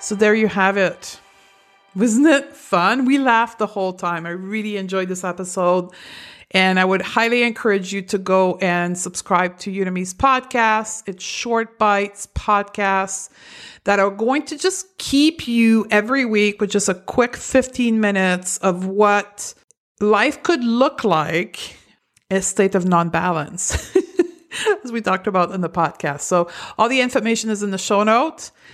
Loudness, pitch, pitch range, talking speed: -19 LUFS, 205 Hz, 190-235 Hz, 160 wpm